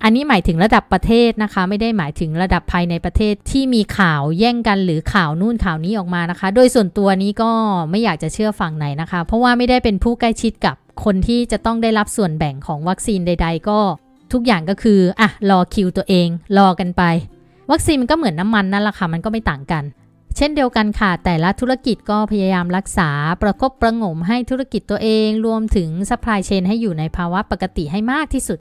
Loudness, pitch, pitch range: -17 LUFS, 205 Hz, 180-225 Hz